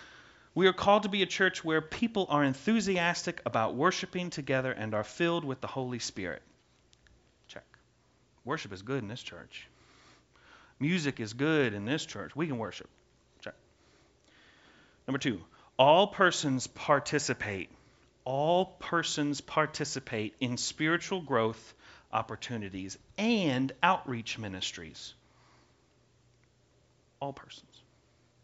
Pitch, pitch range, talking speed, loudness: 140 Hz, 115-175 Hz, 115 wpm, -31 LUFS